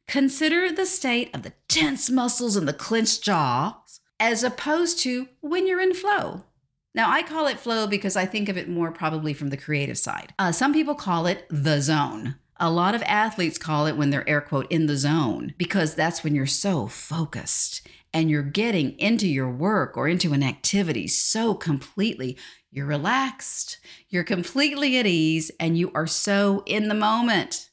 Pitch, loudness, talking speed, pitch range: 195 Hz, -23 LUFS, 185 wpm, 155-245 Hz